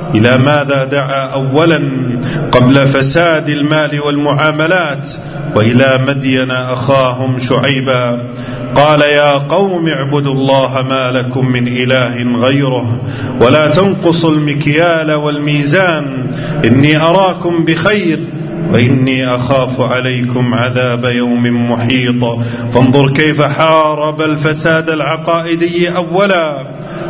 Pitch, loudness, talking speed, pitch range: 140 Hz, -11 LUFS, 90 wpm, 125-155 Hz